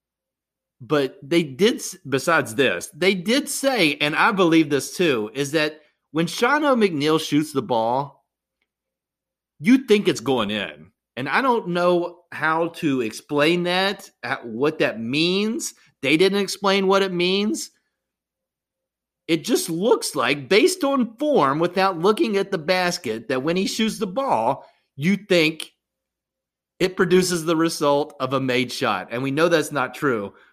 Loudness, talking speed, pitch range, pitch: -21 LUFS, 150 wpm, 150-195 Hz, 175 Hz